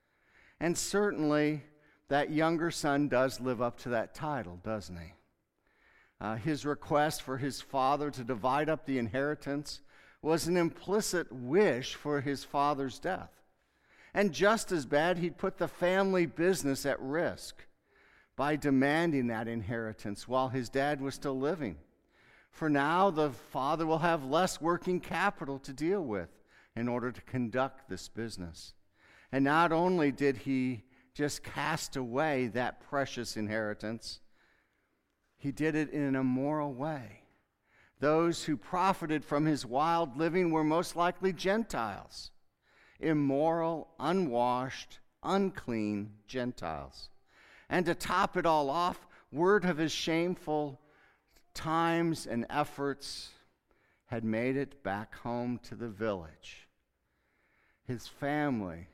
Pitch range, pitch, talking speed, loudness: 125-165 Hz, 140 Hz, 130 wpm, -32 LUFS